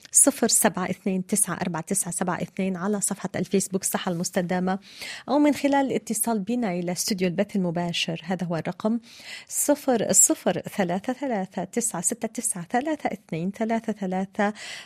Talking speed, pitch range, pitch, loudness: 145 wpm, 185-230 Hz, 200 Hz, -24 LUFS